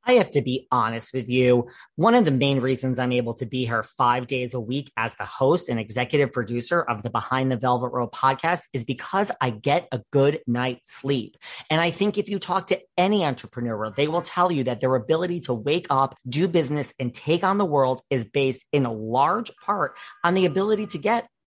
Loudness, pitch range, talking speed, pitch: -24 LUFS, 125-170 Hz, 220 wpm, 135 Hz